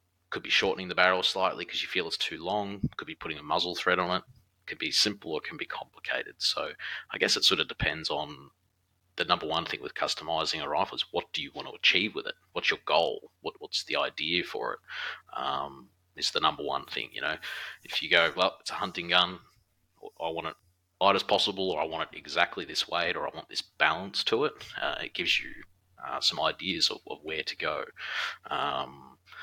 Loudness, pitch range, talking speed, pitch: -29 LUFS, 90-95 Hz, 225 wpm, 90 Hz